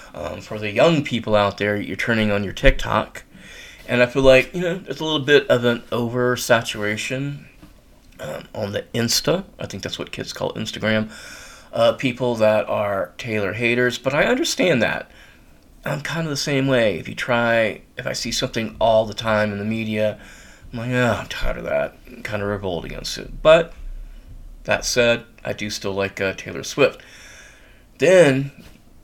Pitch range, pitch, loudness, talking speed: 105-130 Hz, 115 Hz, -20 LUFS, 190 wpm